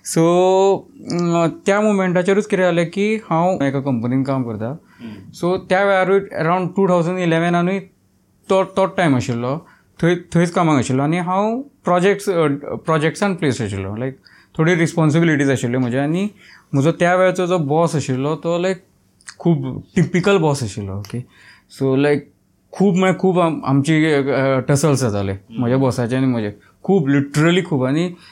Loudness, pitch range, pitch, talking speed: -18 LUFS, 130-185 Hz, 160 Hz, 115 wpm